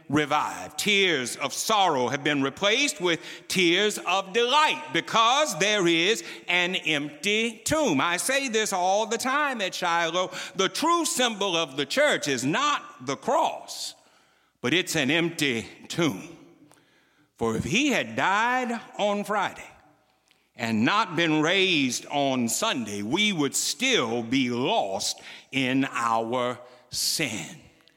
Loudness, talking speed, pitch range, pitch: -24 LUFS, 130 wpm, 145-225 Hz, 180 Hz